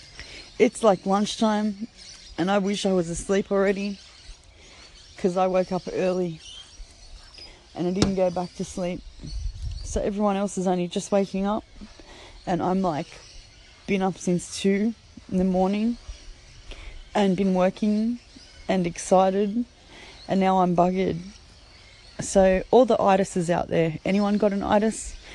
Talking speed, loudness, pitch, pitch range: 140 wpm, -24 LUFS, 190 Hz, 175-205 Hz